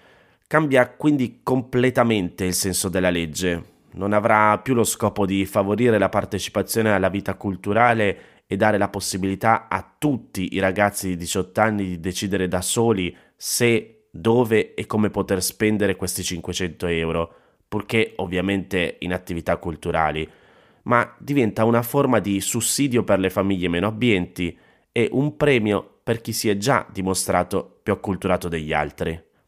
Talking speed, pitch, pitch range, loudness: 145 wpm, 100 Hz, 90-115 Hz, -22 LUFS